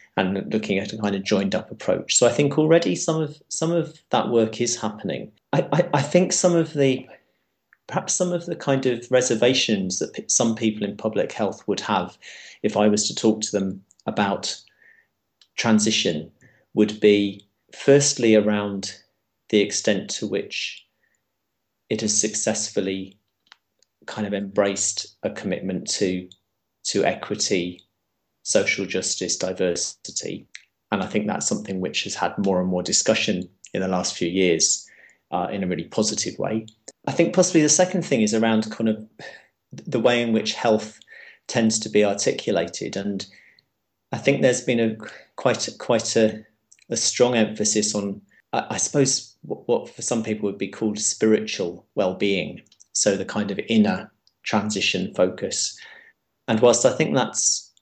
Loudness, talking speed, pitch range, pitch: -22 LUFS, 160 wpm, 100-125 Hz, 110 Hz